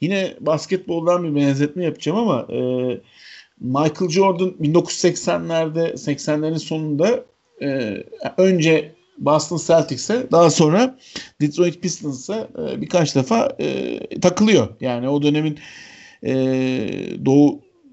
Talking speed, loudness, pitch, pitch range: 100 wpm, -19 LUFS, 160 Hz, 145-185 Hz